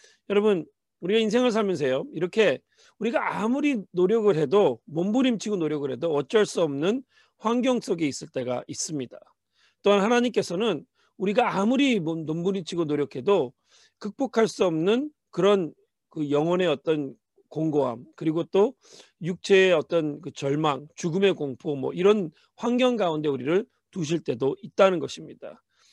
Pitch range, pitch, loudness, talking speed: 155-220 Hz, 190 Hz, -25 LUFS, 305 characters per minute